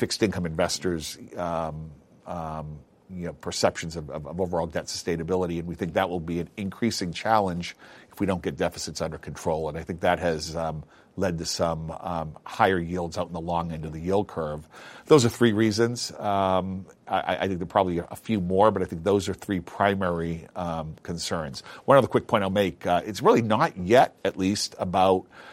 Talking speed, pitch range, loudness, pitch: 200 wpm, 80-95 Hz, -26 LUFS, 90 Hz